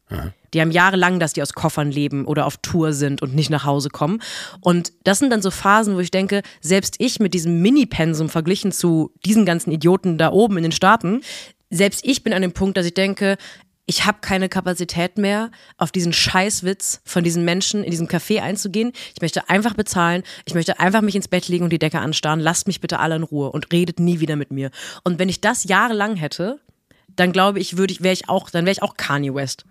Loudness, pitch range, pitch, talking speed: -19 LUFS, 165-195 Hz, 180 Hz, 230 wpm